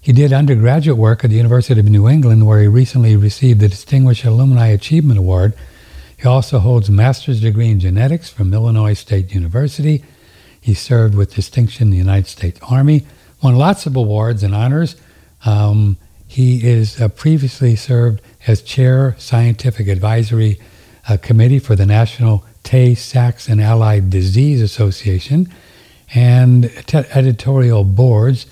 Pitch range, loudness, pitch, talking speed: 105-130 Hz, -13 LUFS, 115 Hz, 145 wpm